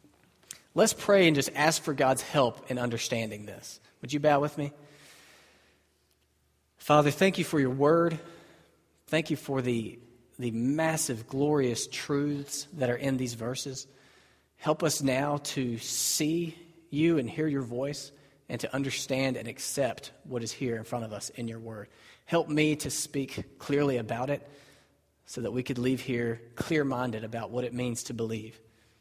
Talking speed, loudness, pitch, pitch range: 170 wpm, -29 LUFS, 130 Hz, 115-145 Hz